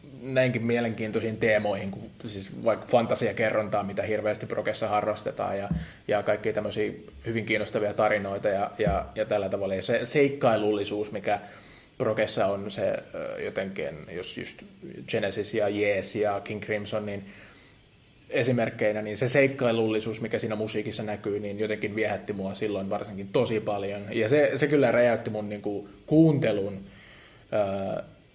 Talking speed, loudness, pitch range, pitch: 140 wpm, -27 LUFS, 100-115 Hz, 105 Hz